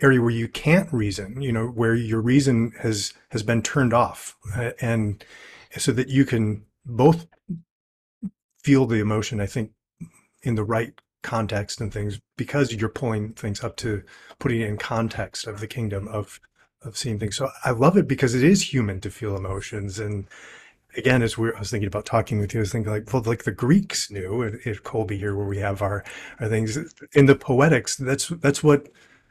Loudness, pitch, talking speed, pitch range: -23 LUFS, 115 Hz, 200 wpm, 105-135 Hz